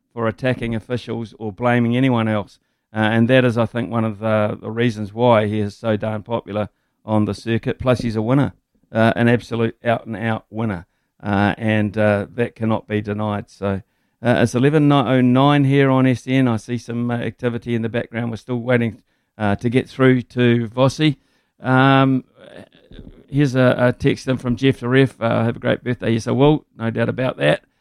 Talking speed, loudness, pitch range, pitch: 200 wpm, -19 LUFS, 110-125 Hz, 115 Hz